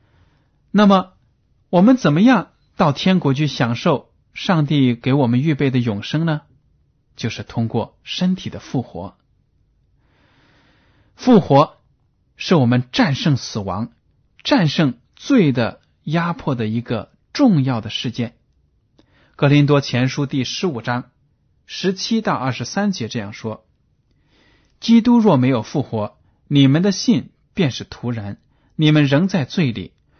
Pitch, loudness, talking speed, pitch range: 140 Hz, -18 LUFS, 190 characters per minute, 120-175 Hz